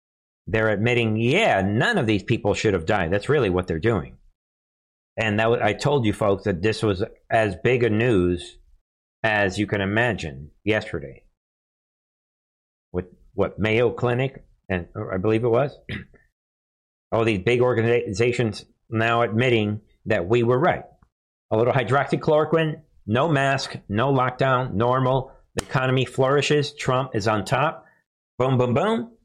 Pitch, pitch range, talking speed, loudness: 115 Hz, 100-125 Hz, 145 wpm, -22 LUFS